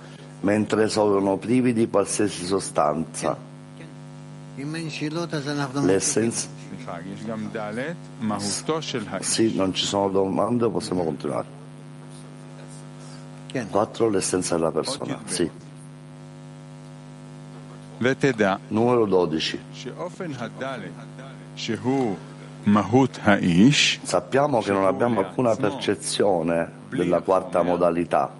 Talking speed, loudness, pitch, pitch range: 65 wpm, -23 LUFS, 105 Hz, 90-125 Hz